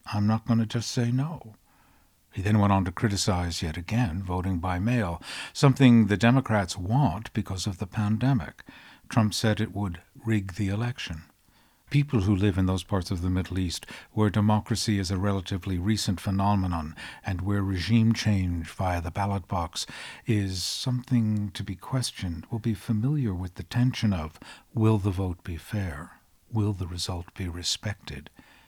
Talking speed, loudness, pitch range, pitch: 165 wpm, -27 LUFS, 95-115 Hz, 100 Hz